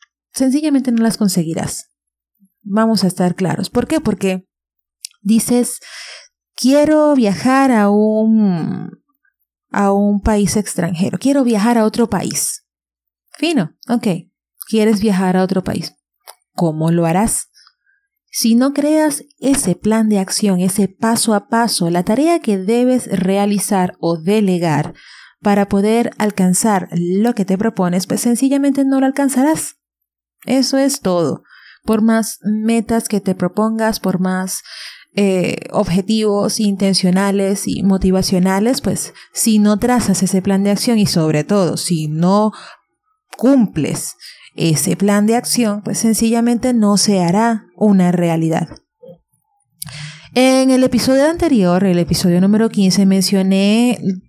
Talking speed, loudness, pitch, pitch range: 125 wpm, -15 LUFS, 205 Hz, 185-235 Hz